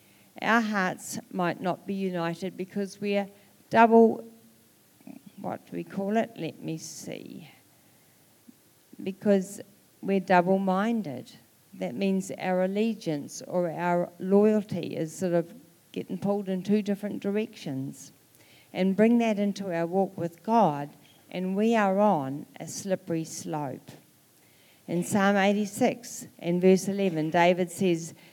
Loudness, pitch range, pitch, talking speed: -27 LUFS, 170-205 Hz, 190 Hz, 125 wpm